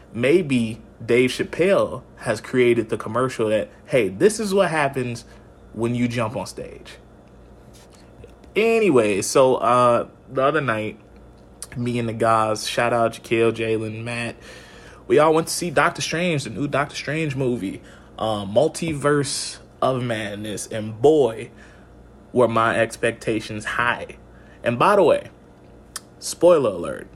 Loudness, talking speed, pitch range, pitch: -21 LUFS, 135 wpm, 110-135 Hz, 115 Hz